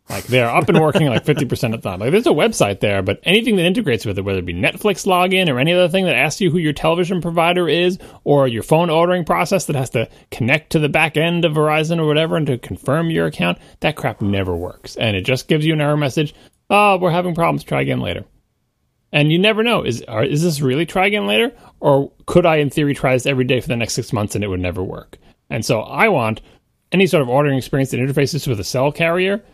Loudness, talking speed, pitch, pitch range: -17 LUFS, 250 wpm, 150 Hz, 125-175 Hz